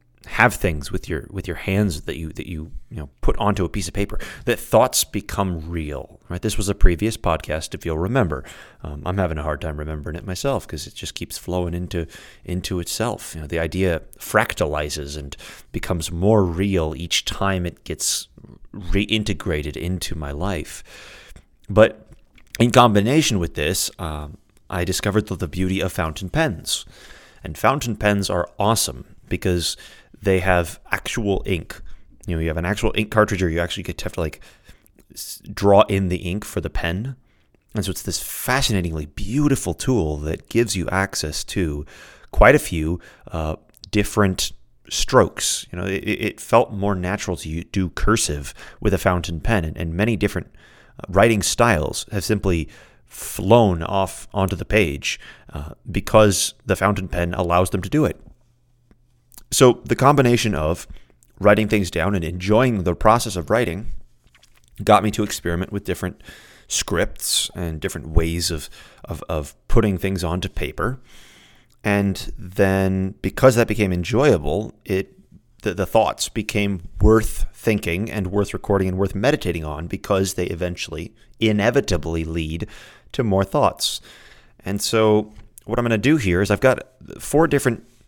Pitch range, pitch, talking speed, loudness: 85-105 Hz, 95 Hz, 165 wpm, -21 LUFS